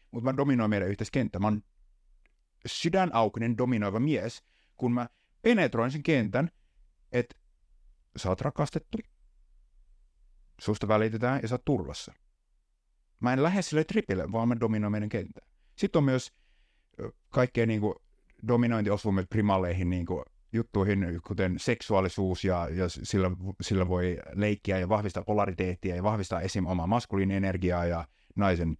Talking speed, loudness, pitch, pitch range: 130 wpm, -29 LUFS, 105 Hz, 90-120 Hz